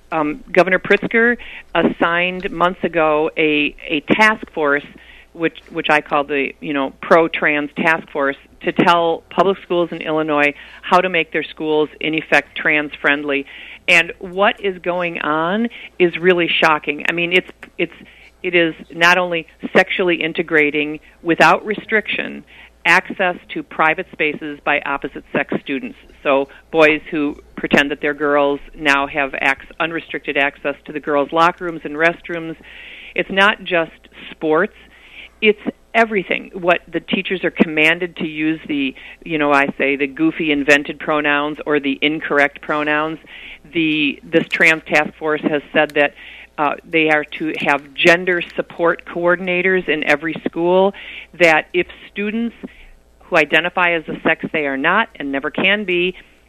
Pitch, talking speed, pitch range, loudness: 160 Hz, 150 wpm, 150-180 Hz, -17 LUFS